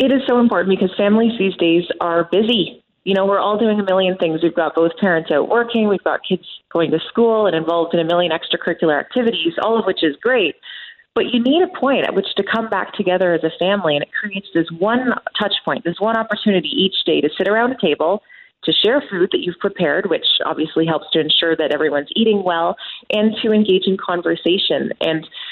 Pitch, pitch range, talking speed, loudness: 195 Hz, 170-225 Hz, 220 wpm, -17 LUFS